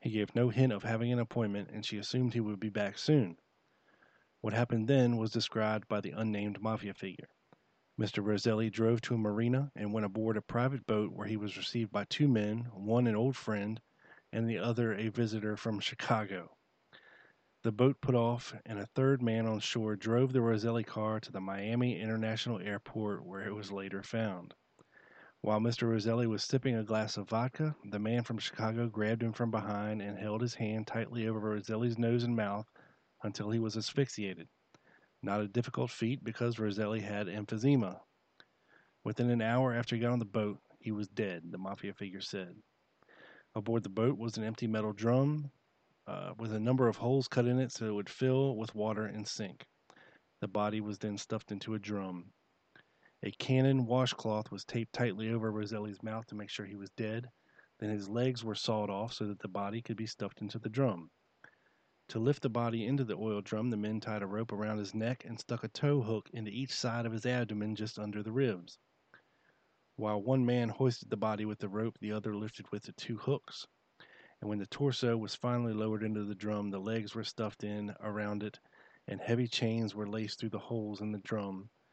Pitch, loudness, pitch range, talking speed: 110 Hz, -35 LUFS, 105-120 Hz, 200 wpm